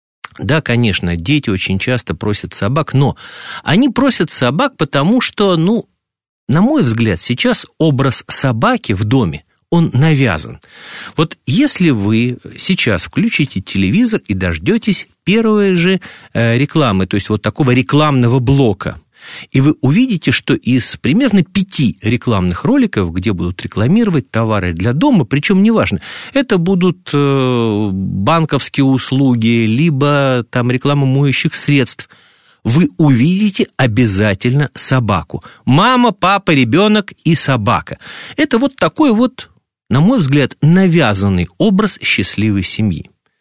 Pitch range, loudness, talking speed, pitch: 115-185 Hz, -13 LUFS, 120 wpm, 140 Hz